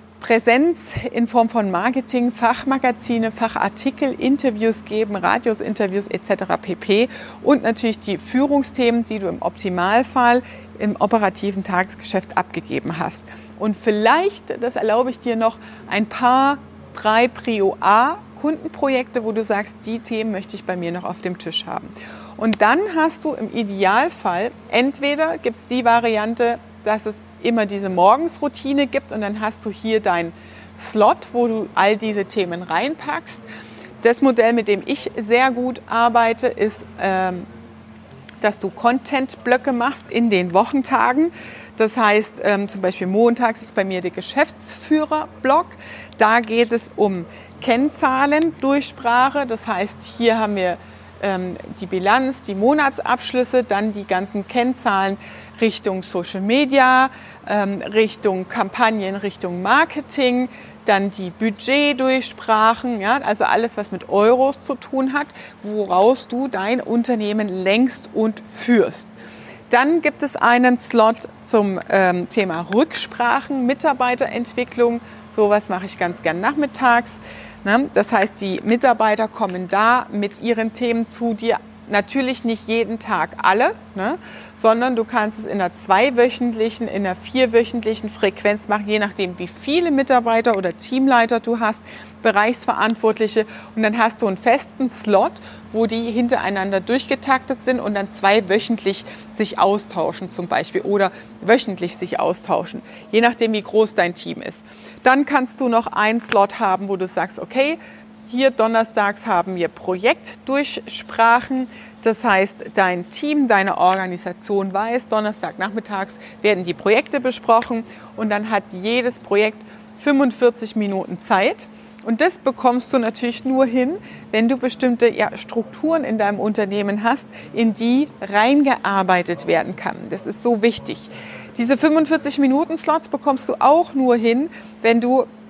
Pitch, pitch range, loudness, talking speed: 225 Hz, 205-250 Hz, -19 LUFS, 135 wpm